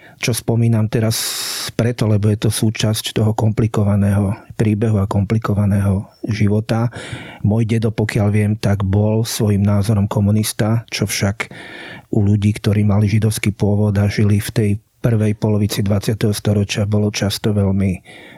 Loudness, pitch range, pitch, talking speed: -17 LUFS, 105-115 Hz, 105 Hz, 135 wpm